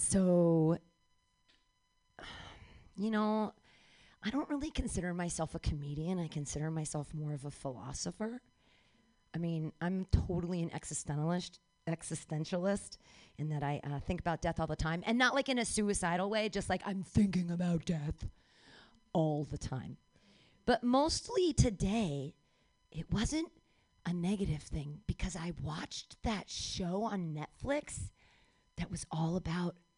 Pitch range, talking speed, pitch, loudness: 155-200 Hz, 140 wpm, 170 Hz, -36 LUFS